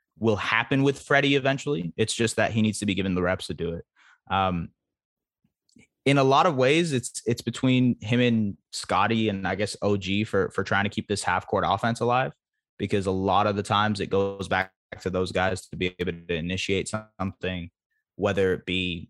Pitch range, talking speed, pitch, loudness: 95-115 Hz, 205 wpm, 100 Hz, -25 LUFS